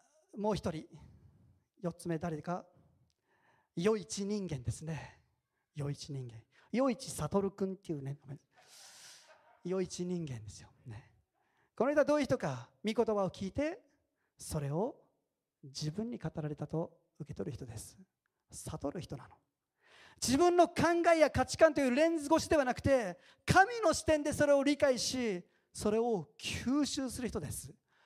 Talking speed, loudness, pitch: 265 characters per minute, -34 LUFS, 200 Hz